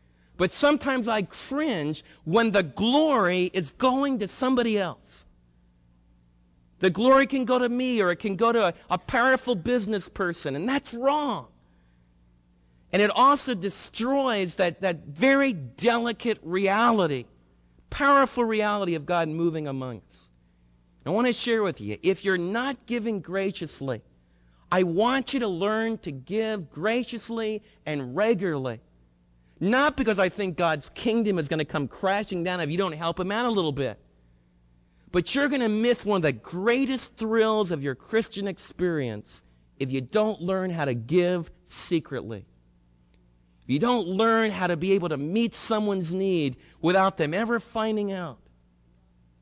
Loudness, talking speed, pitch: -25 LUFS, 155 wpm, 185 Hz